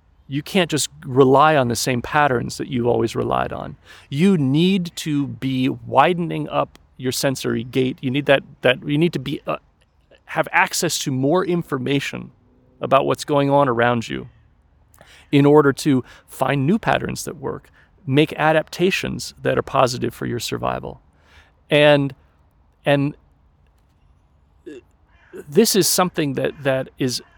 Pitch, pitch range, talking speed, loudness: 135 Hz, 115-150 Hz, 145 wpm, -19 LUFS